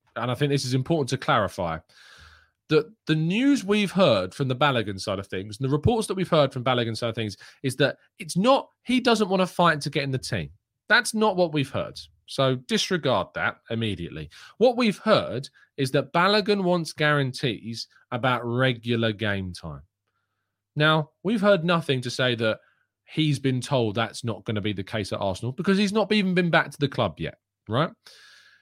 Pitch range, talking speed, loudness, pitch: 115-185 Hz, 200 wpm, -24 LUFS, 140 Hz